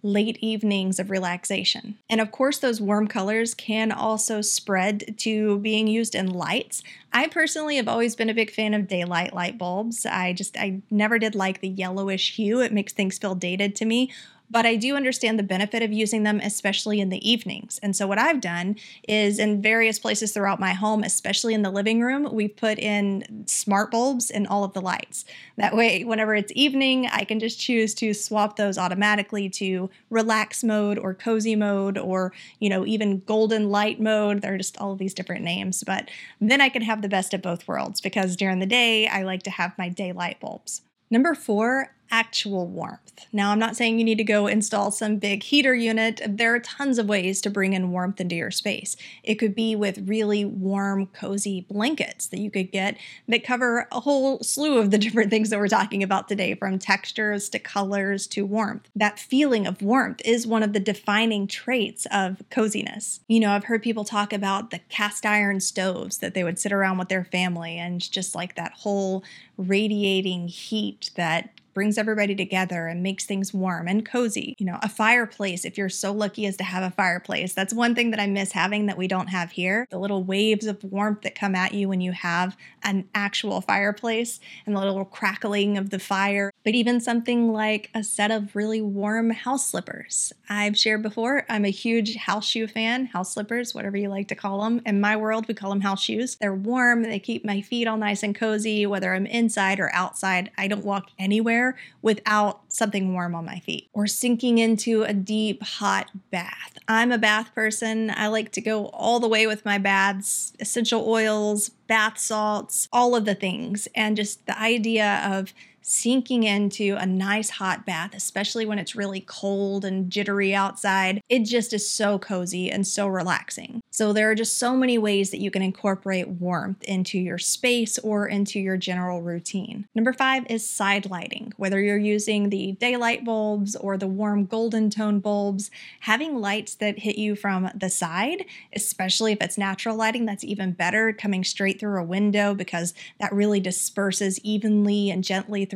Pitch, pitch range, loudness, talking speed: 205 Hz, 195-225 Hz, -24 LUFS, 200 wpm